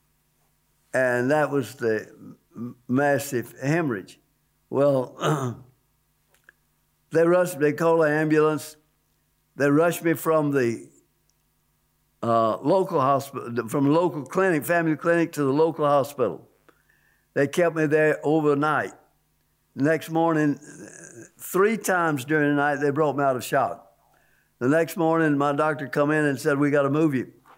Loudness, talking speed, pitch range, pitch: -23 LUFS, 135 wpm, 130-160 Hz, 145 Hz